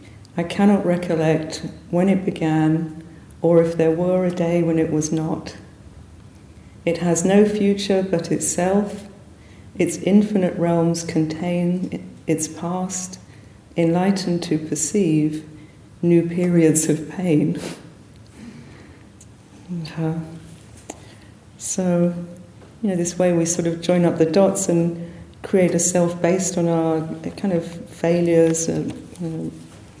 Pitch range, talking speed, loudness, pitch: 155-175 Hz, 120 wpm, -20 LUFS, 165 Hz